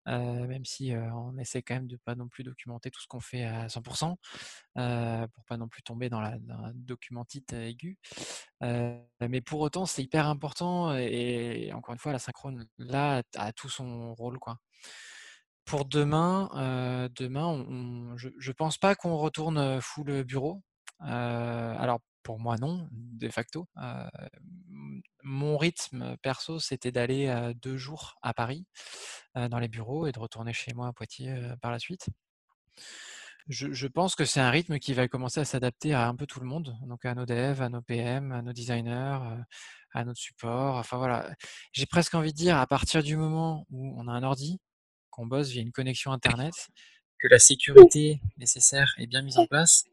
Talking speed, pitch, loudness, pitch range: 195 wpm, 130 Hz, -26 LUFS, 120-150 Hz